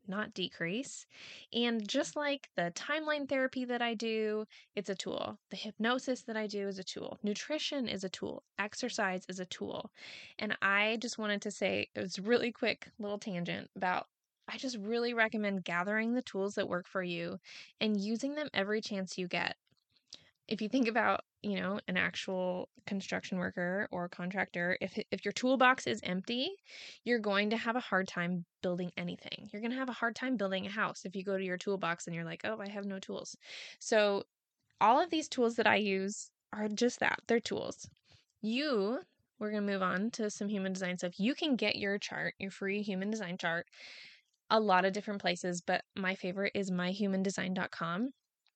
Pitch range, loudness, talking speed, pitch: 190-230 Hz, -35 LUFS, 195 wpm, 205 Hz